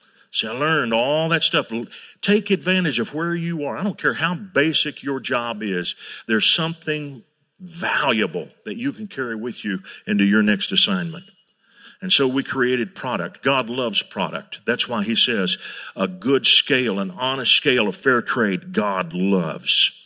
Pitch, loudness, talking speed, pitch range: 150 Hz, -19 LUFS, 170 wpm, 120-185 Hz